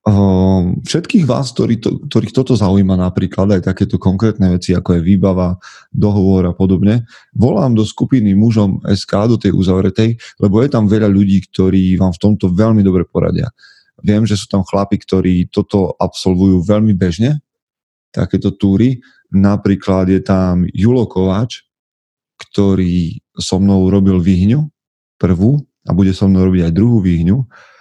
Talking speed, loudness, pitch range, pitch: 145 wpm, -13 LUFS, 95-110 Hz, 100 Hz